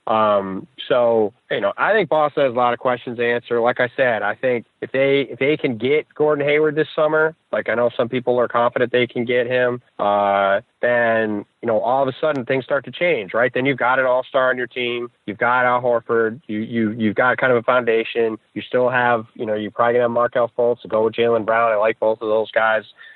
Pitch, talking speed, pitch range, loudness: 120 Hz, 245 wpm, 110-130 Hz, -19 LUFS